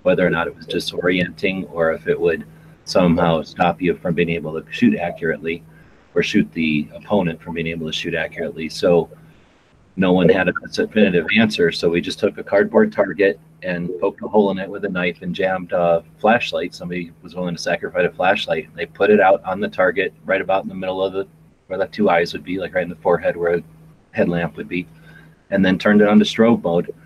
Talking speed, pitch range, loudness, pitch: 225 wpm, 85-100 Hz, -19 LUFS, 90 Hz